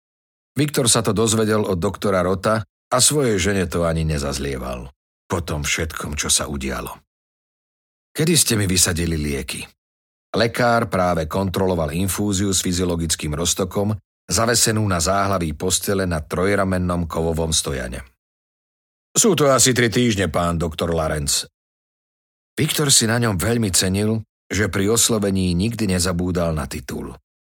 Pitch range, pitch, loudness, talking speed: 80-110 Hz, 95 Hz, -19 LUFS, 130 wpm